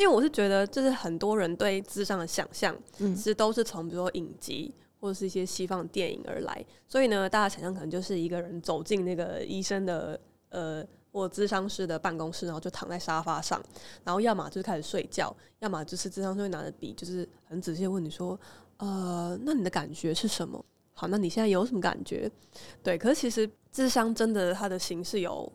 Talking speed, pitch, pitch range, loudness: 325 characters per minute, 190 Hz, 175-205 Hz, -31 LUFS